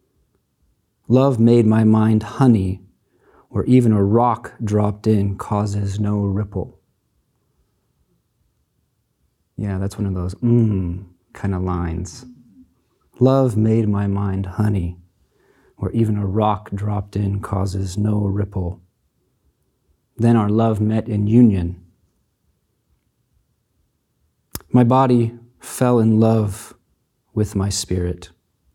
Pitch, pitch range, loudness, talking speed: 105 Hz, 95-115 Hz, -19 LUFS, 105 wpm